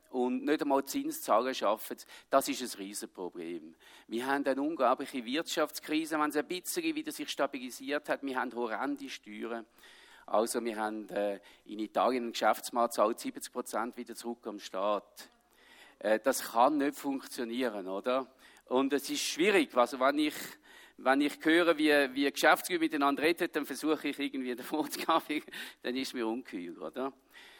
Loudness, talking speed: -32 LUFS, 160 wpm